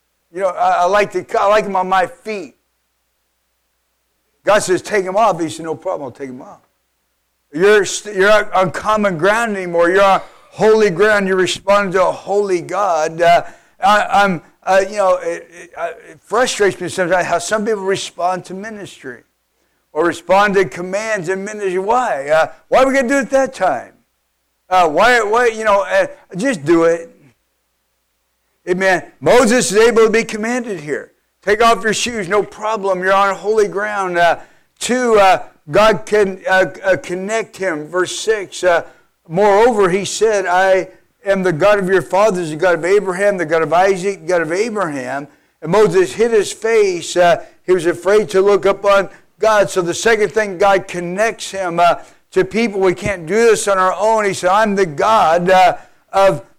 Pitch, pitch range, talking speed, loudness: 195 Hz, 180-215 Hz, 185 wpm, -15 LUFS